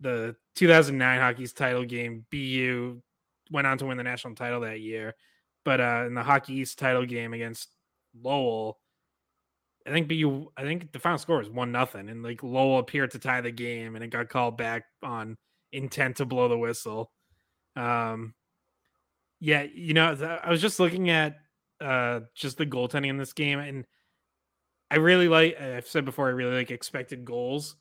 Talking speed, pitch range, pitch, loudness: 180 wpm, 115-145 Hz, 125 Hz, -27 LUFS